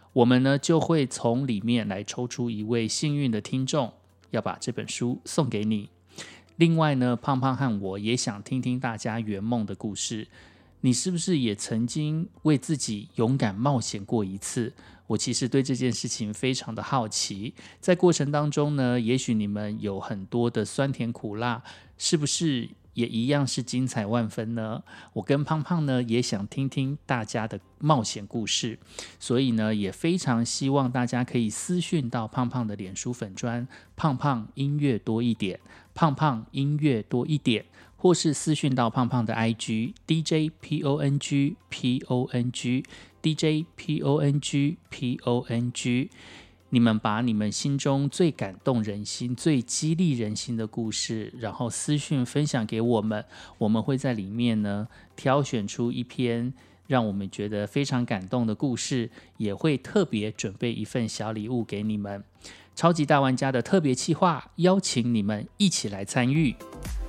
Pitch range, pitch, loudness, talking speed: 110-140 Hz, 120 Hz, -27 LUFS, 245 characters per minute